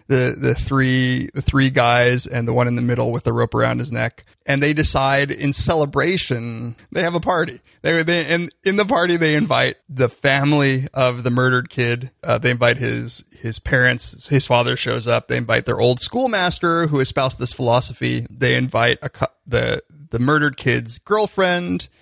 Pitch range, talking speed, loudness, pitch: 120-150 Hz, 185 wpm, -18 LUFS, 130 Hz